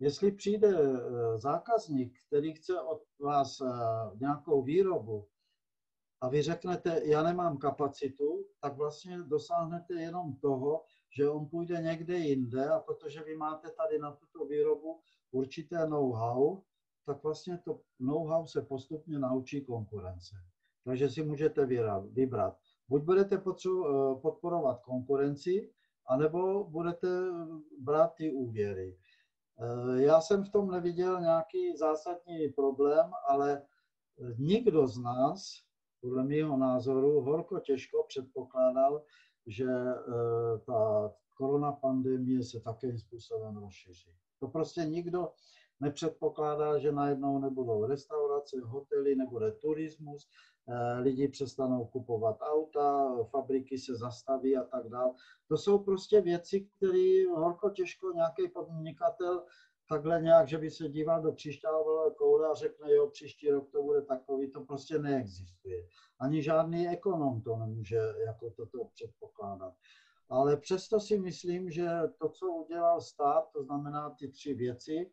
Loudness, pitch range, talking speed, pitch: -33 LUFS, 130-180 Hz, 125 wpm, 150 Hz